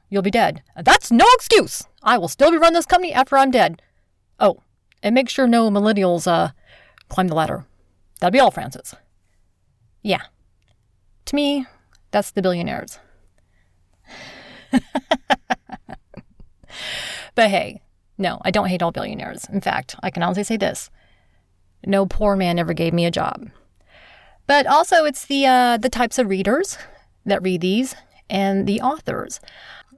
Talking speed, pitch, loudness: 150 wpm, 195 Hz, -19 LUFS